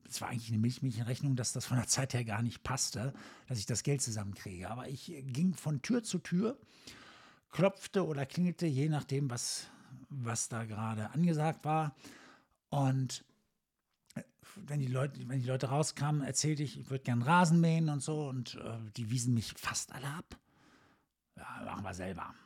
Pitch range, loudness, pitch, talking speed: 120-155 Hz, -35 LUFS, 135 Hz, 180 wpm